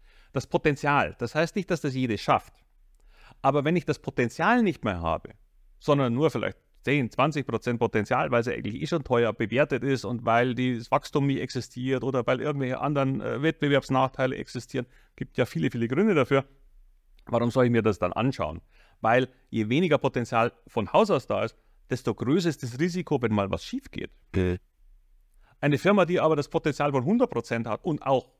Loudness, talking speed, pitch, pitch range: -26 LUFS, 190 wpm, 130 Hz, 115-145 Hz